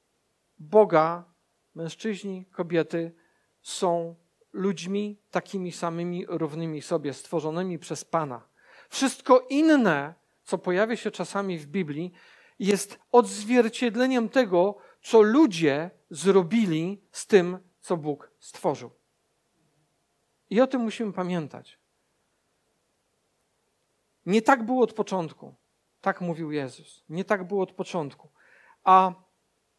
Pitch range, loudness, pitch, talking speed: 170-215 Hz, -25 LUFS, 185 Hz, 100 wpm